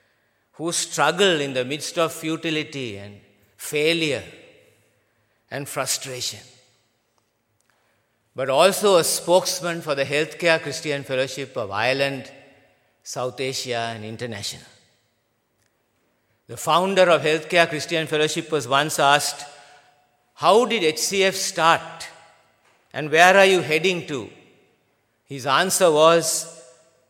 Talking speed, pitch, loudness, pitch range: 105 wpm, 145 Hz, -20 LUFS, 130-165 Hz